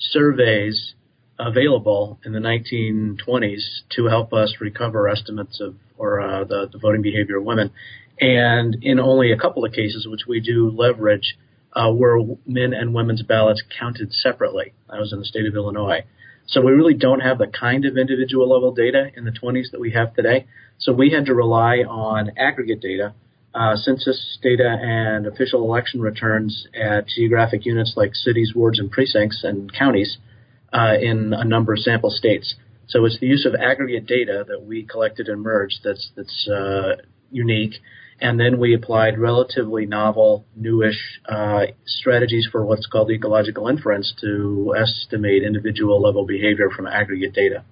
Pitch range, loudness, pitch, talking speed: 105-120 Hz, -19 LUFS, 115 Hz, 165 wpm